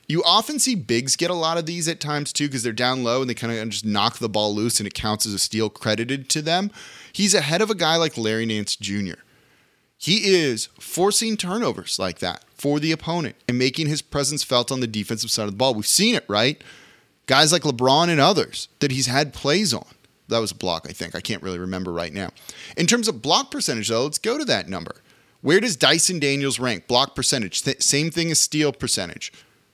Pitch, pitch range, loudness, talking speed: 135 Hz, 110-170 Hz, -21 LUFS, 230 wpm